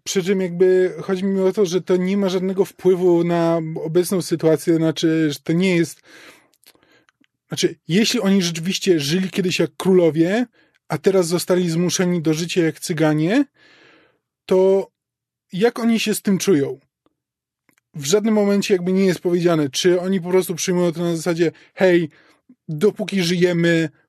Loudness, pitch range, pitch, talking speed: -19 LUFS, 170-195 Hz, 180 Hz, 155 wpm